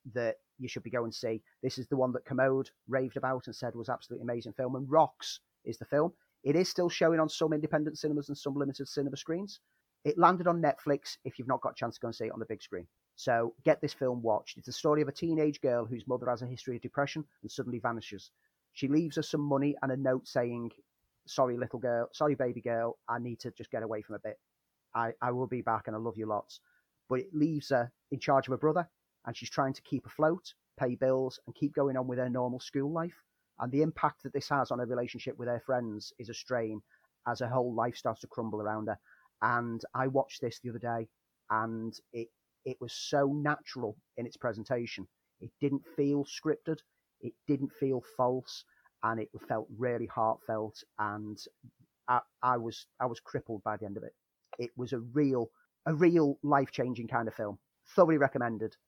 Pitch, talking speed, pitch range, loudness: 125 Hz, 220 wpm, 115-145 Hz, -33 LUFS